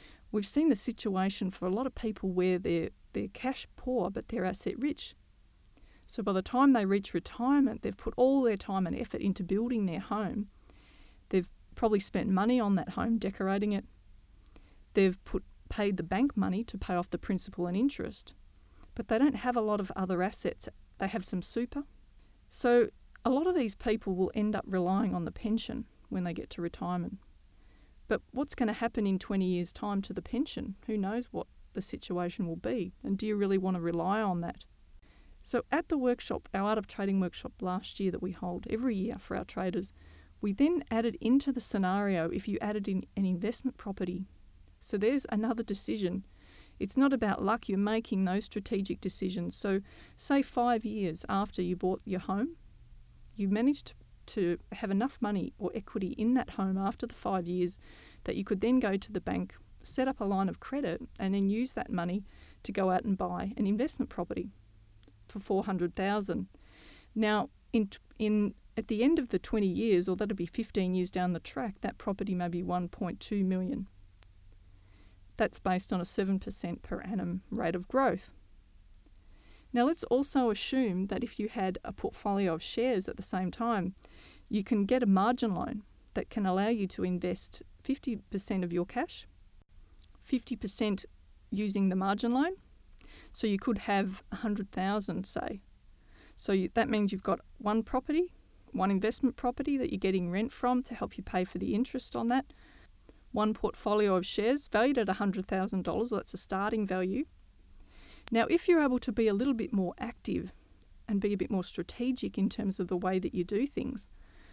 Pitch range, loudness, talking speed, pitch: 185-235 Hz, -32 LUFS, 185 wpm, 205 Hz